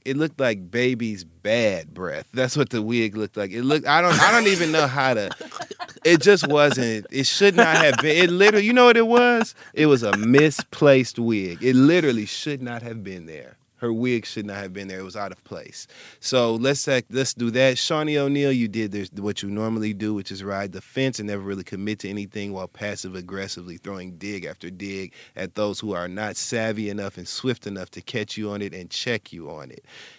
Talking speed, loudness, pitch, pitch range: 225 wpm, -21 LUFS, 110 Hz, 100-135 Hz